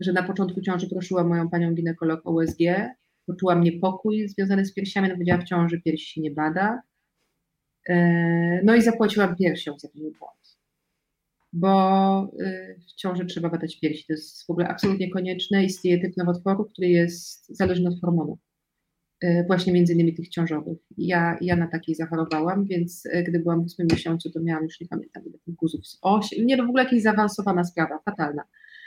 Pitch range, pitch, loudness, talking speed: 165-190 Hz, 175 Hz, -24 LUFS, 170 wpm